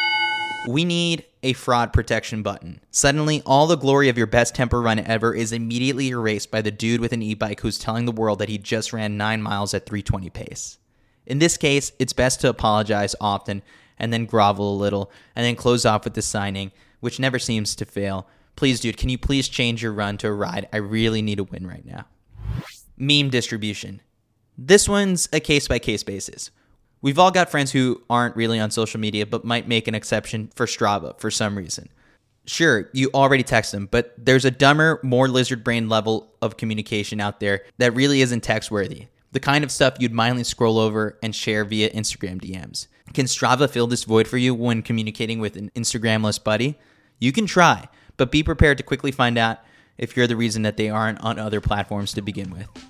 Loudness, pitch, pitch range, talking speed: -21 LUFS, 115 Hz, 105-130 Hz, 205 wpm